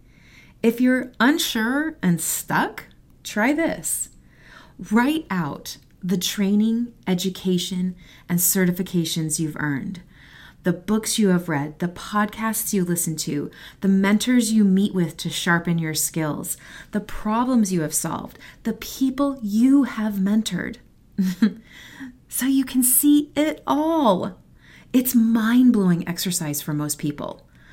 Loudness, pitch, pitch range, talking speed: -22 LUFS, 200 Hz, 175-235 Hz, 125 wpm